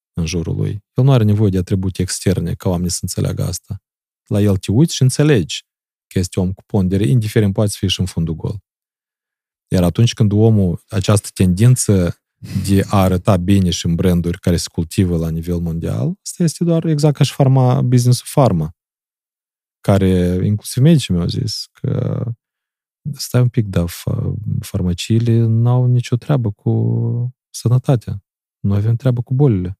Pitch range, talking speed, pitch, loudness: 95-125 Hz, 165 wpm, 110 Hz, -16 LUFS